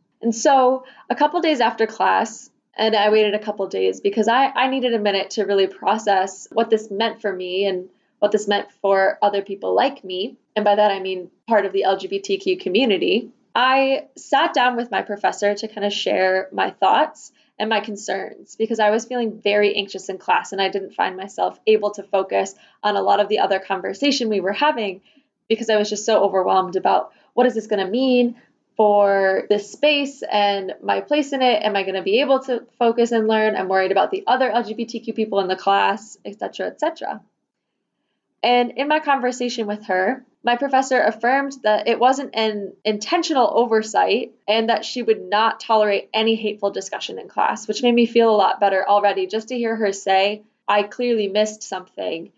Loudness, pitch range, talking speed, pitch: -20 LUFS, 200-245 Hz, 205 wpm, 215 Hz